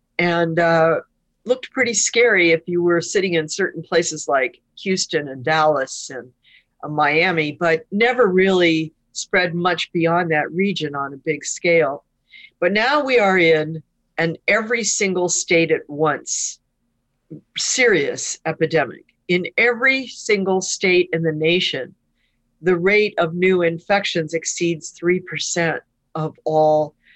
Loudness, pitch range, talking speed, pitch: -18 LUFS, 155-190 Hz, 135 wpm, 170 Hz